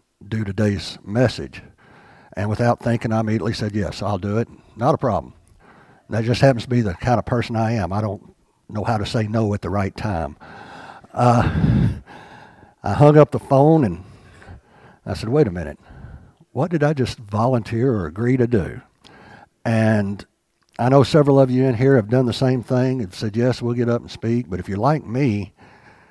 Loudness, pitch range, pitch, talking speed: -20 LUFS, 100-125 Hz, 115 Hz, 195 wpm